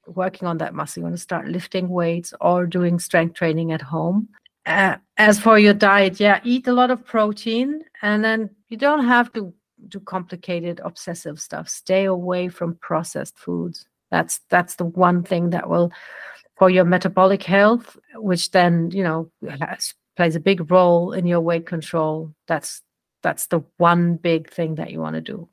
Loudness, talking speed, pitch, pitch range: -20 LUFS, 180 wpm, 180 Hz, 170-205 Hz